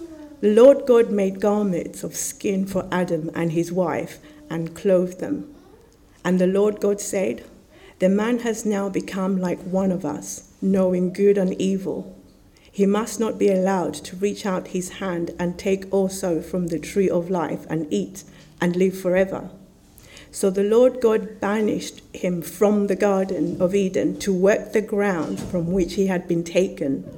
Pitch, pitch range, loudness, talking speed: 190 Hz, 175-205 Hz, -22 LUFS, 170 wpm